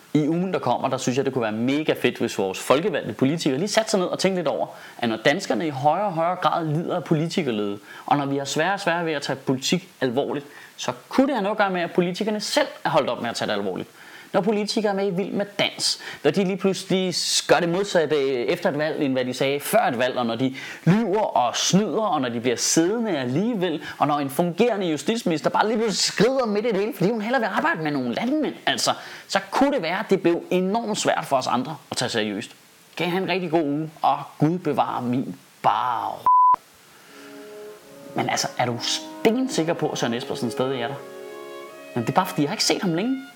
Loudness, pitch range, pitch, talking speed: -23 LUFS, 140-205 Hz, 170 Hz, 245 wpm